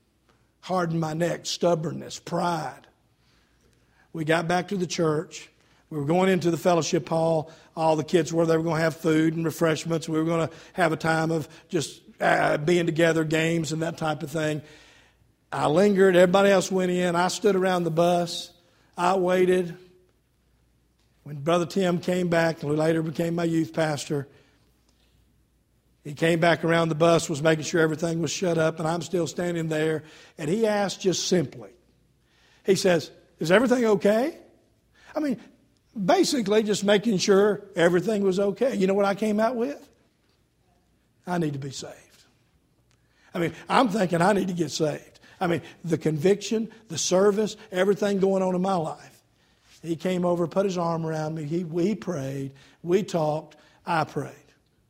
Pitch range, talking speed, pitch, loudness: 160-185 Hz, 175 wpm, 170 Hz, -24 LUFS